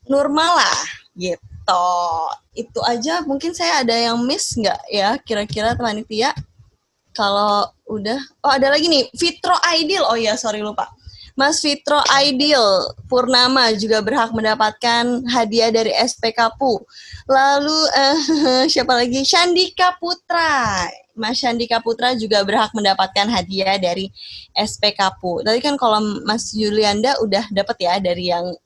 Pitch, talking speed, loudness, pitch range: 235 Hz, 135 wpm, -17 LUFS, 210-280 Hz